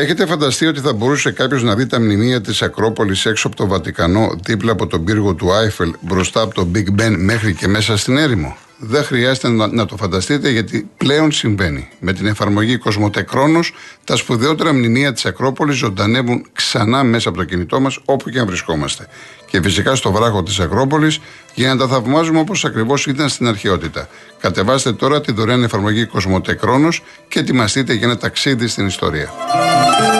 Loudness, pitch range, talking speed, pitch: -15 LUFS, 105-135 Hz, 175 wpm, 115 Hz